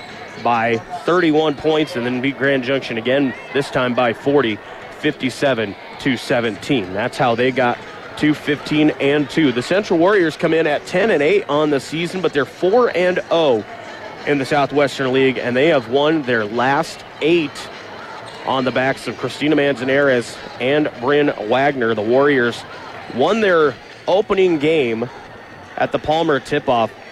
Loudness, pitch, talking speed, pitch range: -17 LUFS, 140 Hz, 160 wpm, 130-155 Hz